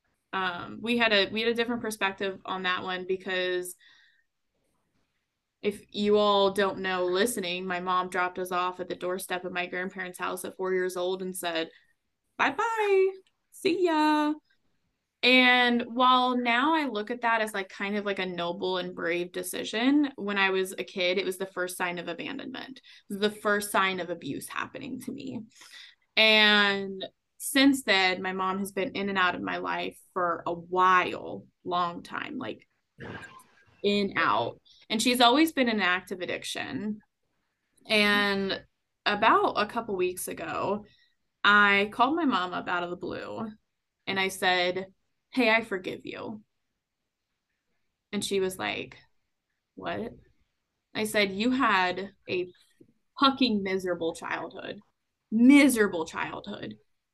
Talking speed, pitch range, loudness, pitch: 150 wpm, 180-235 Hz, -27 LUFS, 195 Hz